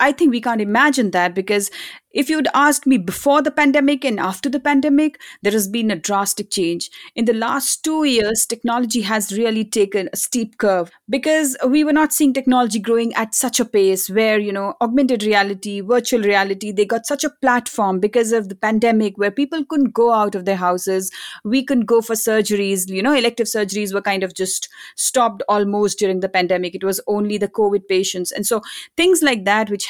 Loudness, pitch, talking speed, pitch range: -18 LUFS, 220 Hz, 205 wpm, 200-260 Hz